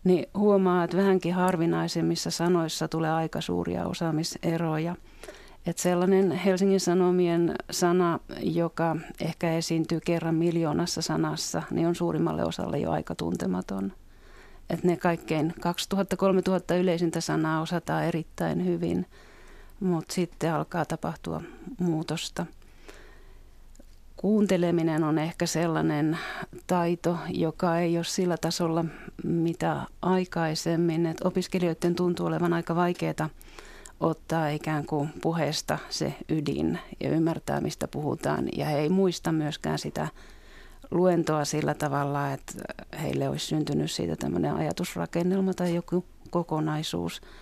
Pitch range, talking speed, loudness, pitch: 155-180 Hz, 115 wpm, -28 LUFS, 170 Hz